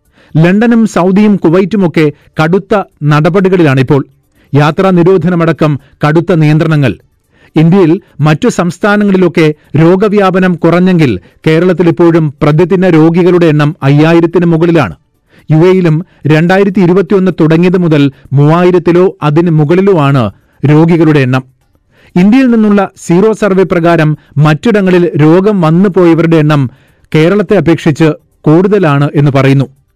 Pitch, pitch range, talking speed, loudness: 165 Hz, 150-185 Hz, 90 wpm, -7 LUFS